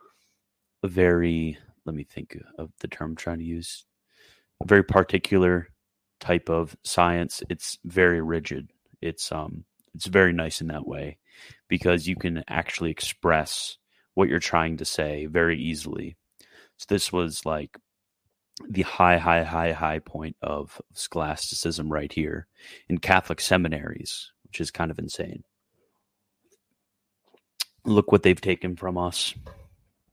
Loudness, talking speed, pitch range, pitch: -25 LUFS, 135 wpm, 80-90 Hz, 85 Hz